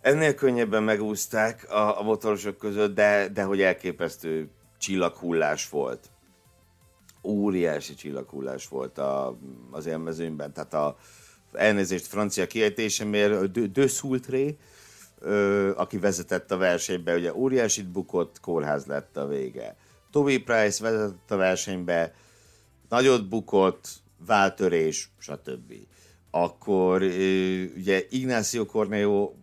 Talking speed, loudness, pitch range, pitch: 110 wpm, -26 LUFS, 85-110 Hz, 100 Hz